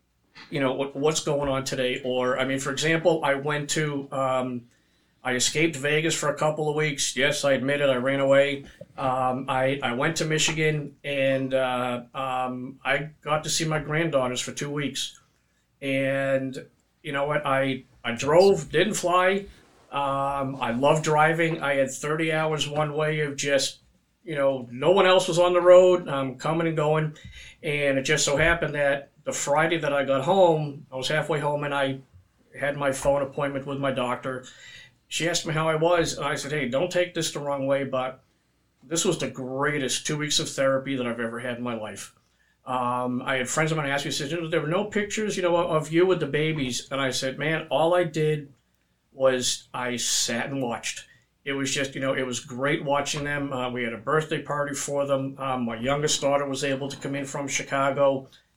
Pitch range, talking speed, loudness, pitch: 135-155 Hz, 205 wpm, -25 LUFS, 140 Hz